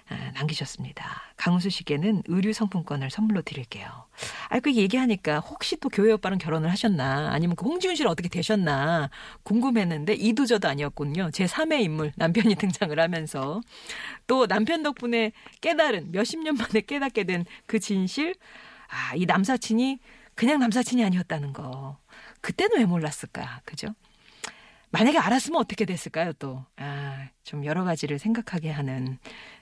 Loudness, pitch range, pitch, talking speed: -26 LUFS, 155-230 Hz, 195 Hz, 335 characters per minute